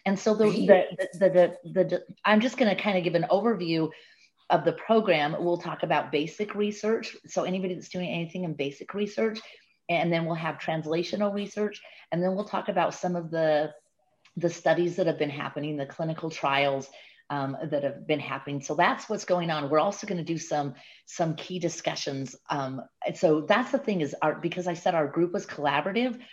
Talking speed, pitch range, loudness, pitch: 205 wpm, 155-195 Hz, -27 LUFS, 170 Hz